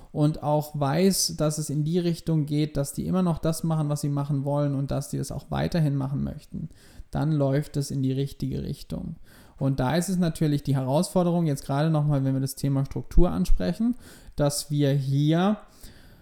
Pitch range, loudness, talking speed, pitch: 140-165 Hz, -26 LUFS, 205 wpm, 150 Hz